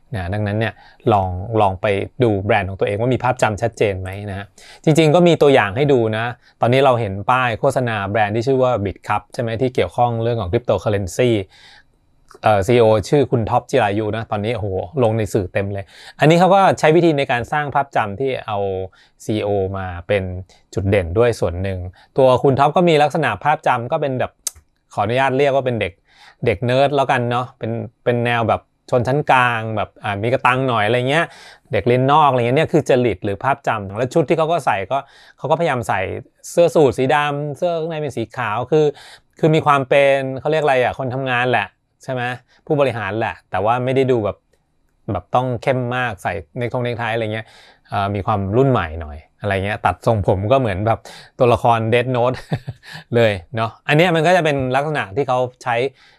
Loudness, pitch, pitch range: -18 LUFS, 120 Hz, 105-135 Hz